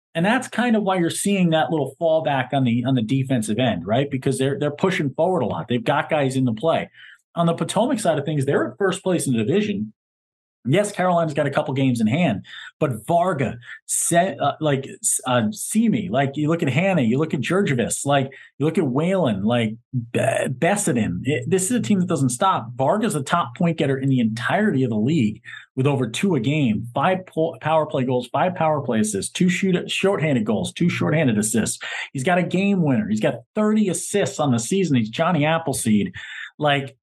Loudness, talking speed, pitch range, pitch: -21 LUFS, 215 wpm, 135-185 Hz, 155 Hz